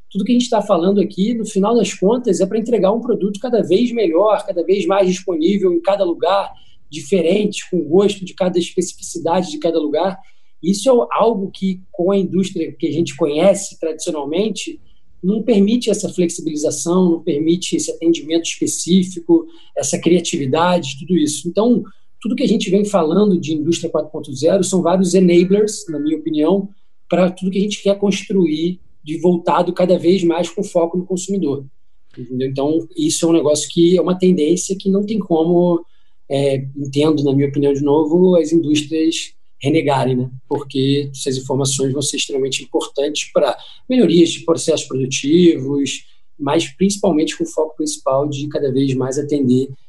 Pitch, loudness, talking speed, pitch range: 170 Hz, -17 LUFS, 165 wpm, 155-195 Hz